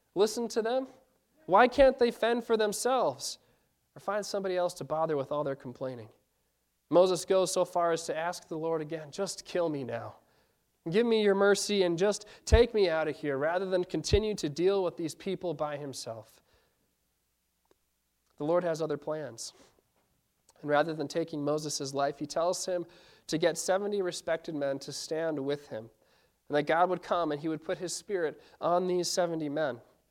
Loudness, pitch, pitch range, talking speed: -30 LUFS, 170 Hz, 150-195 Hz, 185 wpm